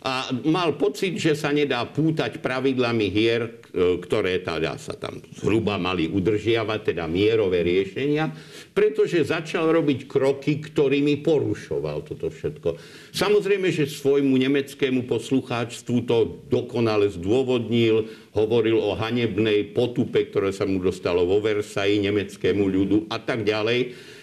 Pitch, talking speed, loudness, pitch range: 130 Hz, 125 wpm, -23 LUFS, 110-150 Hz